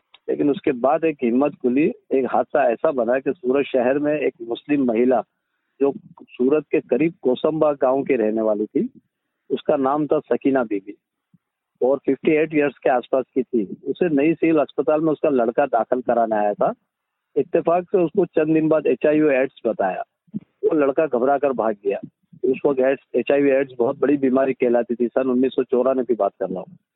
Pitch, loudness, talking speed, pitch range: 135 Hz, -20 LUFS, 180 wpm, 125-150 Hz